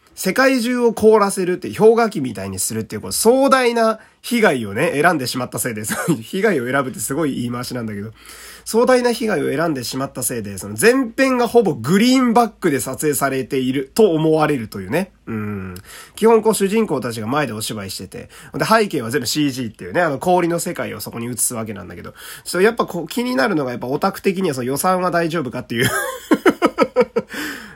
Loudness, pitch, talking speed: -18 LUFS, 160 Hz, 415 characters per minute